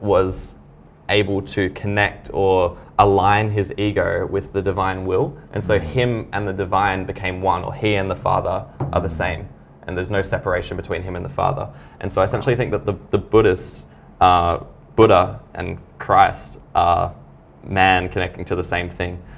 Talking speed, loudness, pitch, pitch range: 175 wpm, -20 LUFS, 95 Hz, 90-100 Hz